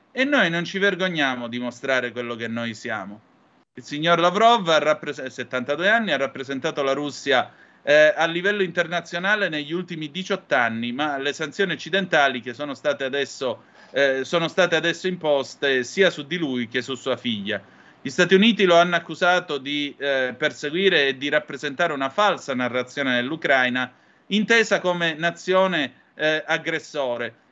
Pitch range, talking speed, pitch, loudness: 130-175 Hz, 155 wpm, 150 Hz, -22 LUFS